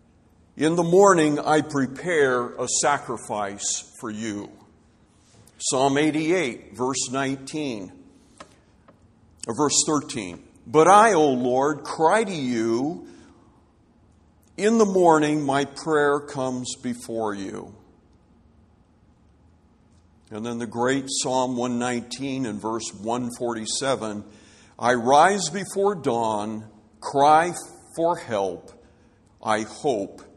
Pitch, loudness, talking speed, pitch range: 125 Hz, -22 LUFS, 95 wpm, 110-150 Hz